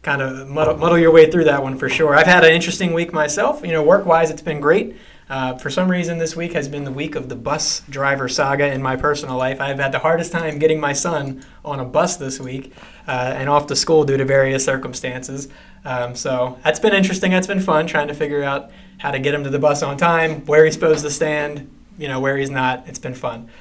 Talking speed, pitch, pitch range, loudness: 250 wpm, 150 Hz, 135-160 Hz, -17 LUFS